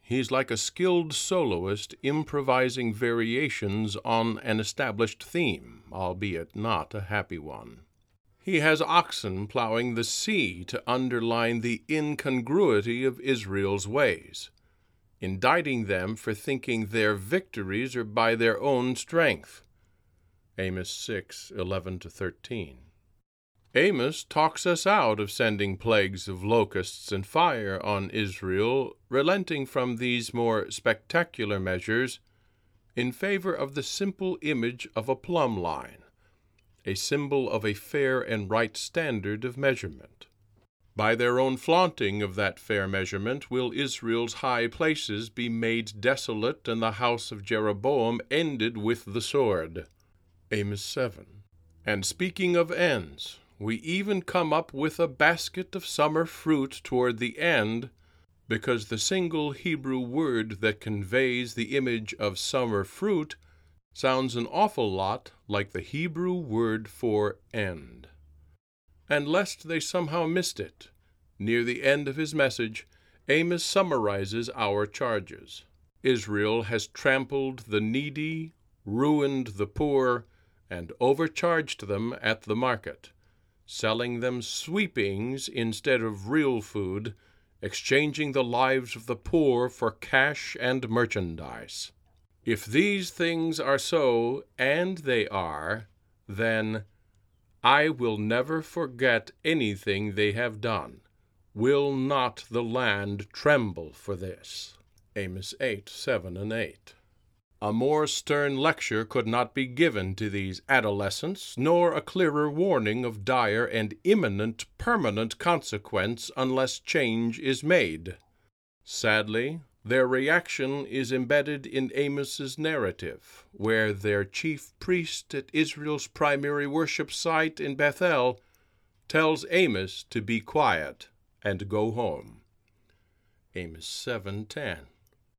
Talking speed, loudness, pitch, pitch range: 125 wpm, -28 LUFS, 115 Hz, 100-140 Hz